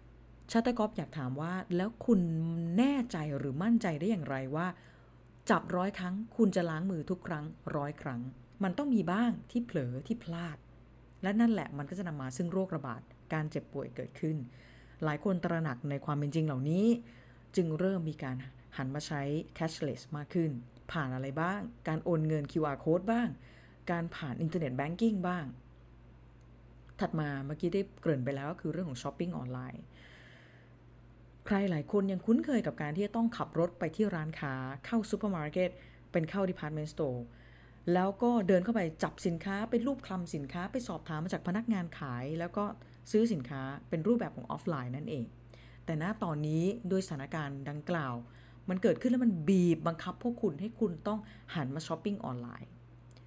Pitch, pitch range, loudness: 165 Hz, 140-195 Hz, -34 LUFS